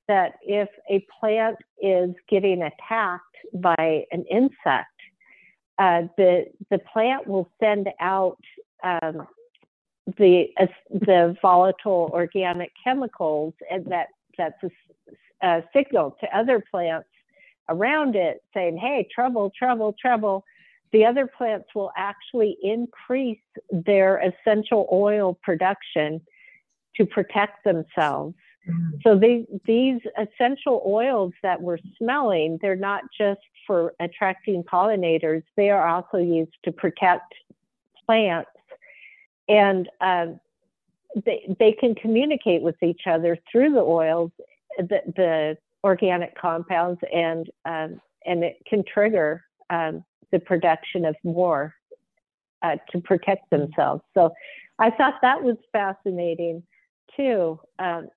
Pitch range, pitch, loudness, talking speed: 175-220 Hz, 190 Hz, -23 LUFS, 115 wpm